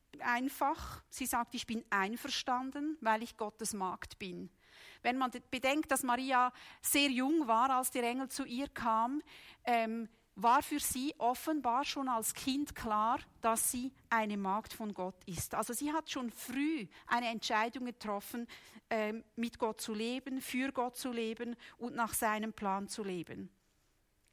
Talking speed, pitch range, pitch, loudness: 160 wpm, 220-265 Hz, 240 Hz, -36 LUFS